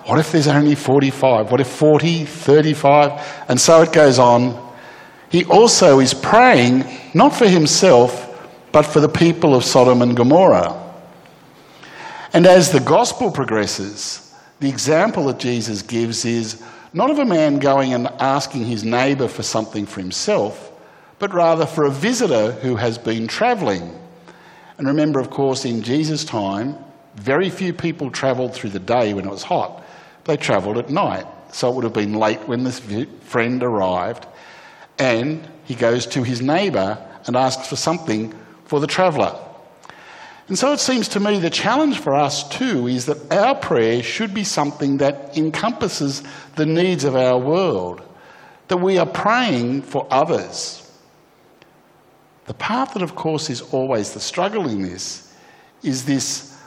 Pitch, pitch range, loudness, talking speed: 140 Hz, 120-160 Hz, -17 LUFS, 160 wpm